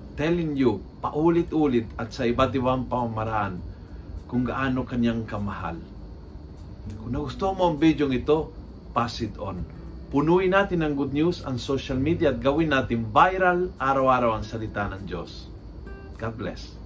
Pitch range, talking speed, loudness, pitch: 100-145 Hz, 145 wpm, -25 LUFS, 120 Hz